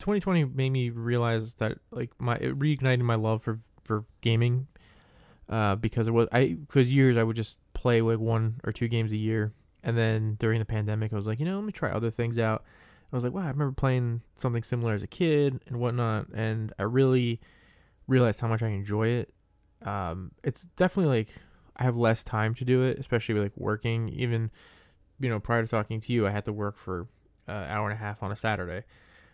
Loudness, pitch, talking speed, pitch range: -28 LUFS, 115 Hz, 220 wpm, 110-125 Hz